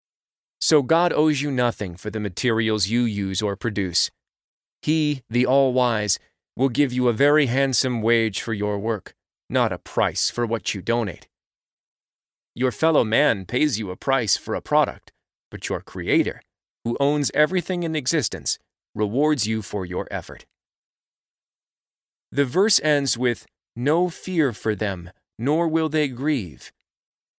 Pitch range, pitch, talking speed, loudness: 110-150 Hz, 125 Hz, 150 wpm, -22 LUFS